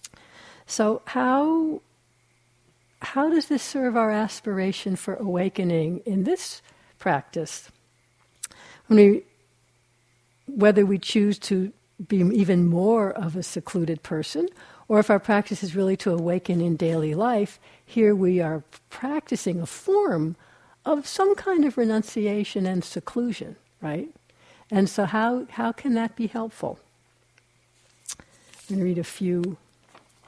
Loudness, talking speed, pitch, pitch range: -24 LUFS, 130 wpm, 200 Hz, 175-230 Hz